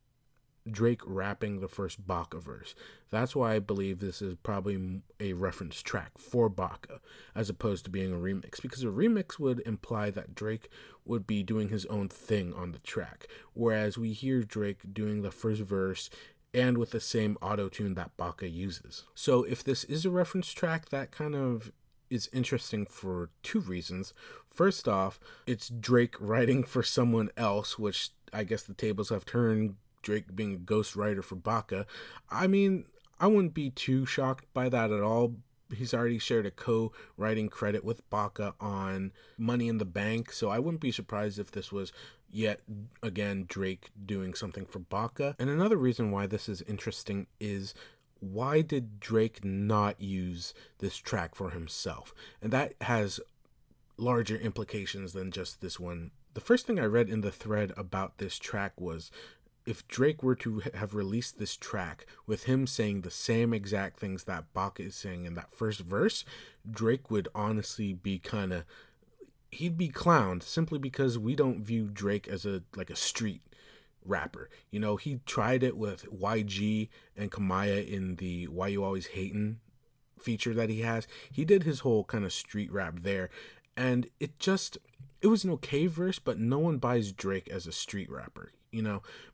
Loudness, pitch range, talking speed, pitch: -33 LUFS, 100-125 Hz, 175 wpm, 110 Hz